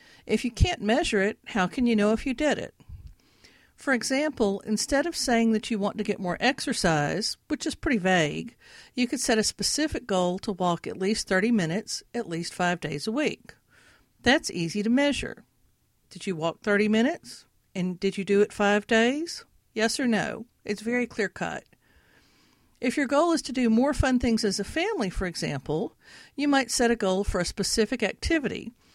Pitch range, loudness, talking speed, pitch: 200-260 Hz, -26 LUFS, 195 wpm, 225 Hz